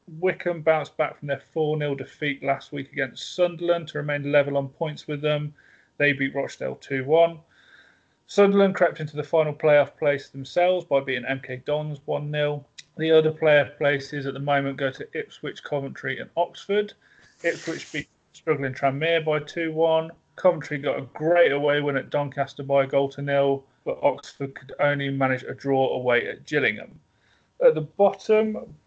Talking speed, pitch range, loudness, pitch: 175 wpm, 140-165 Hz, -24 LUFS, 145 Hz